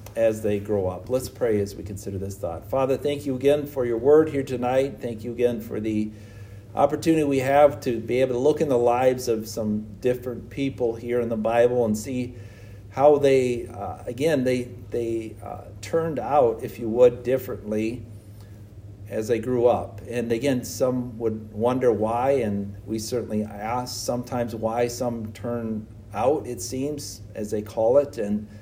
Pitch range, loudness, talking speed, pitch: 105-125 Hz, -24 LUFS, 180 wpm, 115 Hz